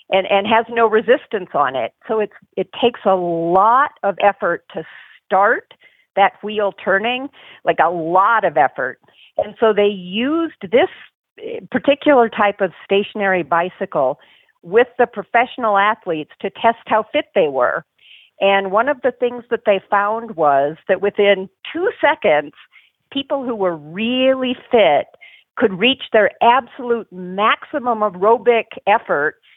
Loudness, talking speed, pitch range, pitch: -17 LUFS, 140 wpm, 195-245 Hz, 220 Hz